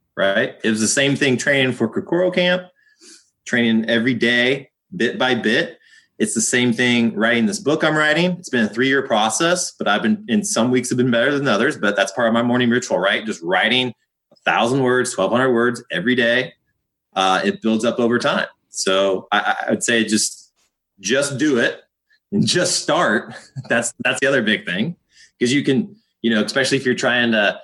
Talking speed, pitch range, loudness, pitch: 200 wpm, 115-155 Hz, -18 LUFS, 125 Hz